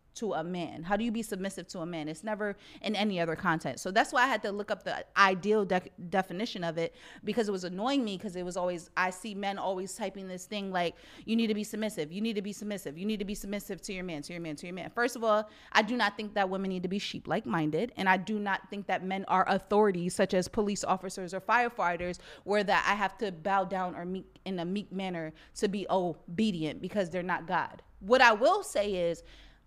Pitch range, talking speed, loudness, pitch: 180-210 Hz, 255 wpm, -31 LUFS, 195 Hz